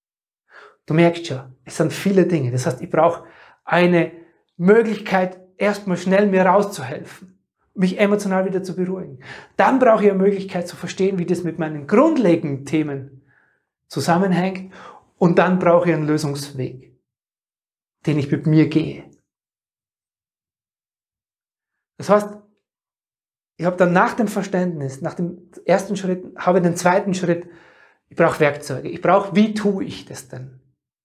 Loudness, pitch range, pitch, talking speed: -19 LUFS, 160-190 Hz, 175 Hz, 140 wpm